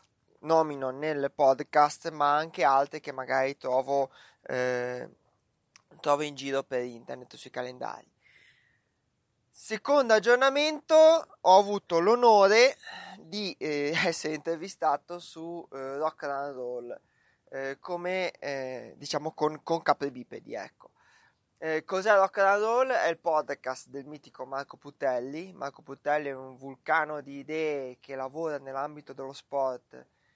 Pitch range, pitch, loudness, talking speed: 135-170 Hz, 150 Hz, -27 LUFS, 120 wpm